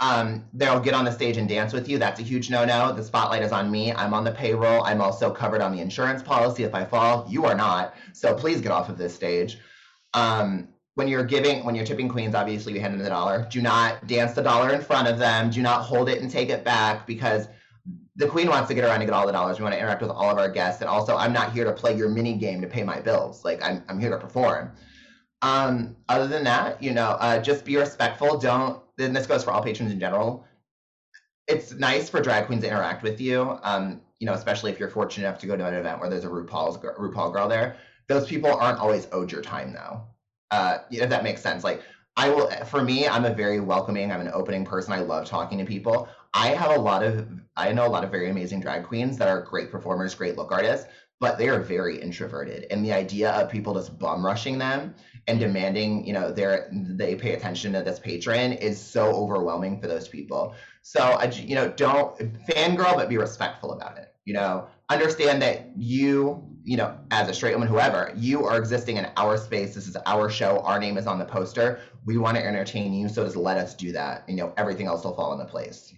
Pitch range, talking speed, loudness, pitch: 105-125 Hz, 240 wpm, -25 LUFS, 115 Hz